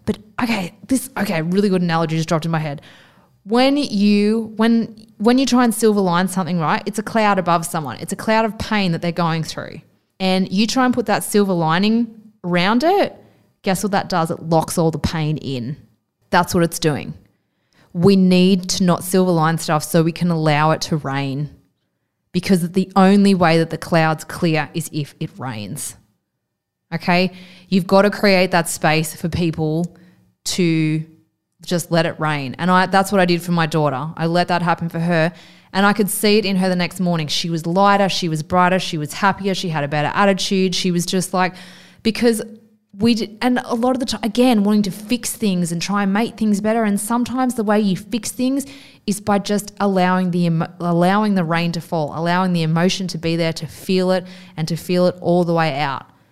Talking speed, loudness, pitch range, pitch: 210 wpm, -18 LUFS, 165-205 Hz, 185 Hz